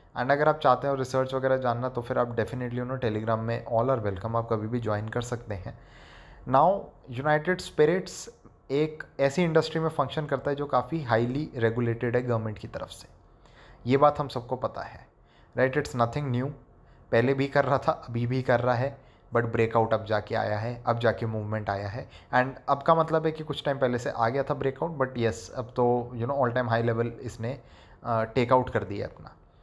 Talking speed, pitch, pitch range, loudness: 210 wpm, 125 Hz, 115-140 Hz, -27 LUFS